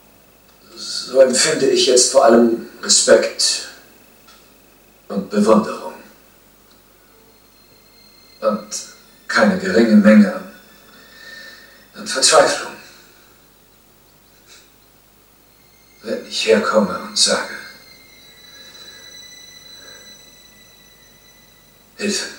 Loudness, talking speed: -15 LUFS, 55 wpm